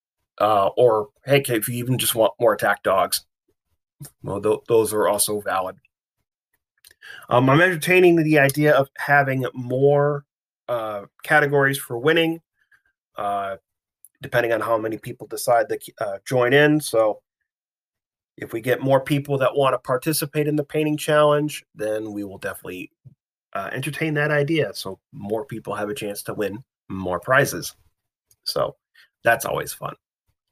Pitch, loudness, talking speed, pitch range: 135 Hz, -21 LUFS, 150 wpm, 110-150 Hz